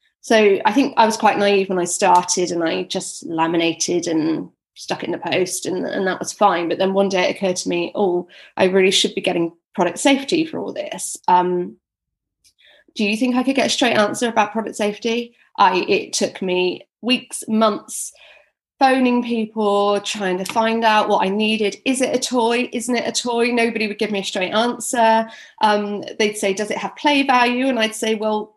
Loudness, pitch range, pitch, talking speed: -19 LUFS, 190-240 Hz, 215 Hz, 210 wpm